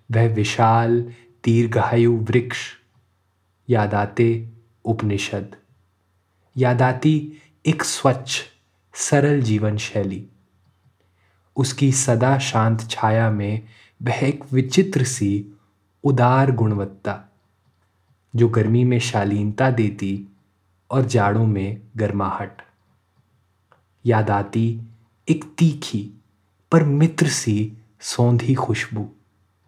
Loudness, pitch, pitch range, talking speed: -20 LUFS, 115 Hz, 100-125 Hz, 85 wpm